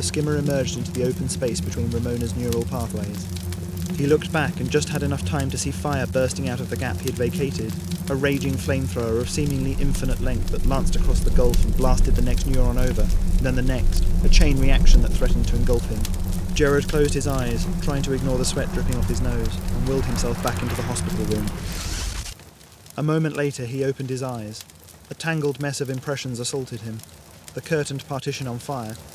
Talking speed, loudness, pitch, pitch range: 205 wpm, -24 LUFS, 110 Hz, 90-135 Hz